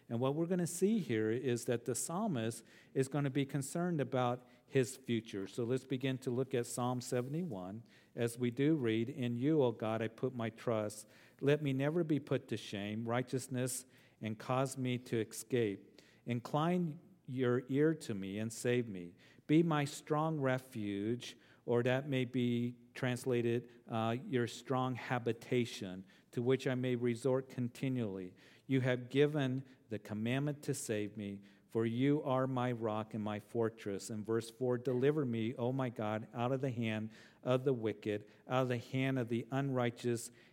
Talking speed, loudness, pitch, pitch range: 175 wpm, -37 LUFS, 125 Hz, 115-135 Hz